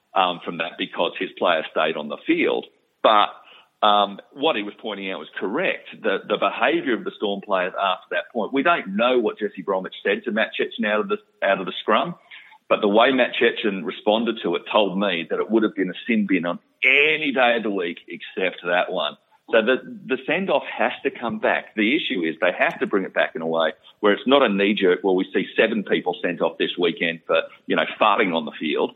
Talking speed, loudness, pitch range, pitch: 240 wpm, -22 LUFS, 95-115 Hz, 105 Hz